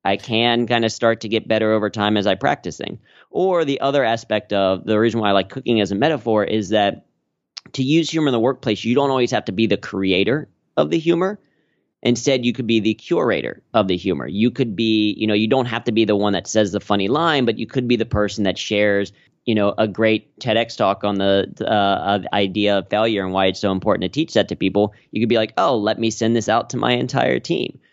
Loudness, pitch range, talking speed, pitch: -19 LUFS, 100-120 Hz, 250 wpm, 110 Hz